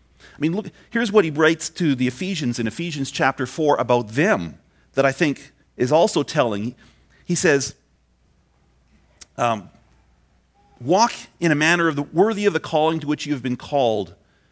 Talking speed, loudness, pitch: 170 wpm, -21 LUFS, 135 Hz